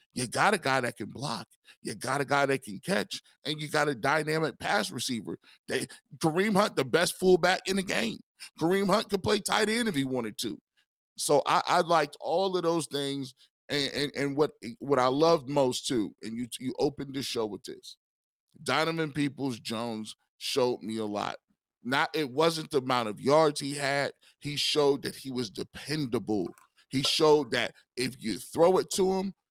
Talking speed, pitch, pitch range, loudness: 195 wpm, 145 Hz, 130-165 Hz, -29 LUFS